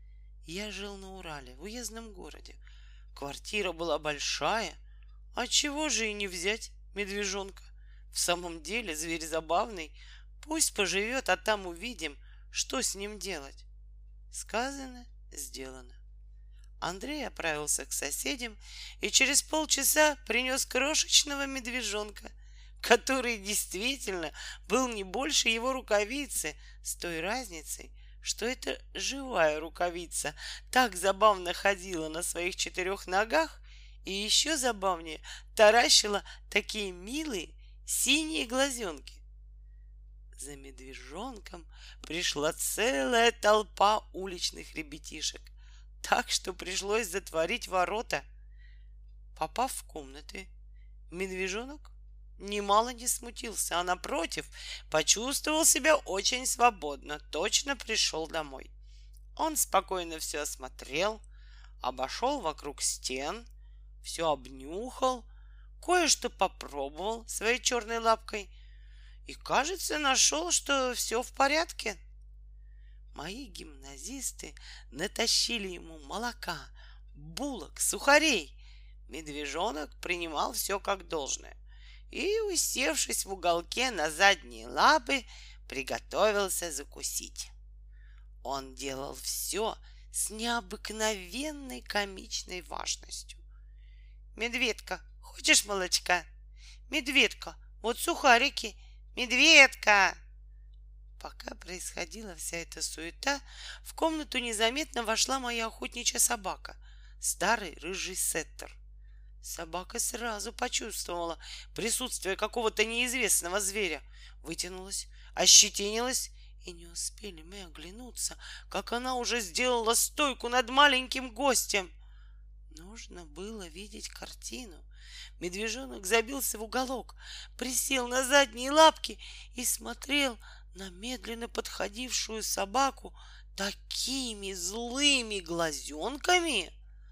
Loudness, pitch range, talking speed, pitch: -29 LUFS, 150-245 Hz, 95 wpm, 200 Hz